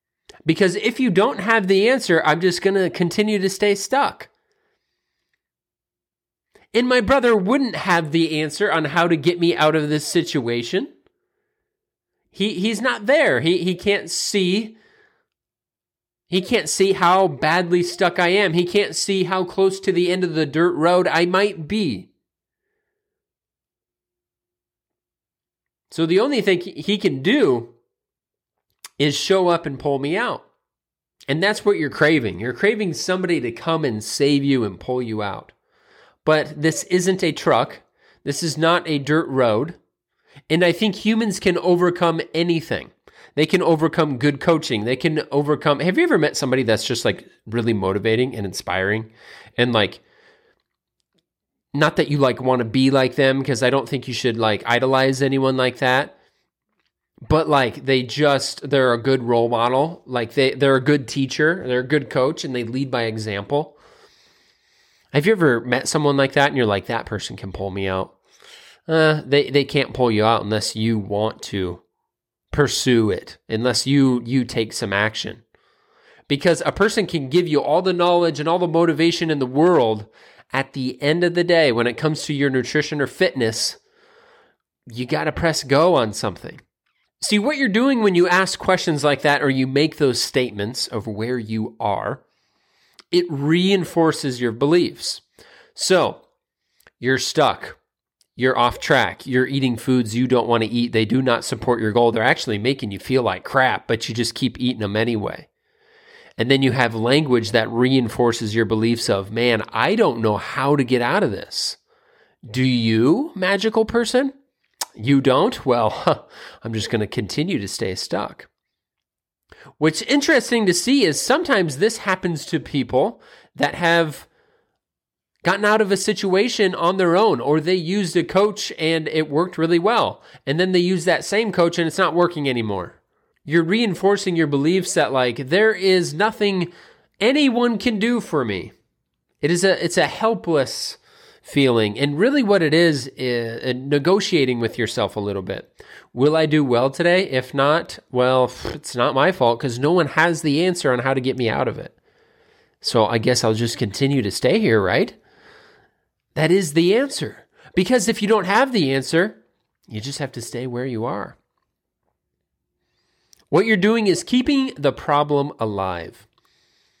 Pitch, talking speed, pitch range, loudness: 155 Hz, 170 wpm, 125-185 Hz, -19 LUFS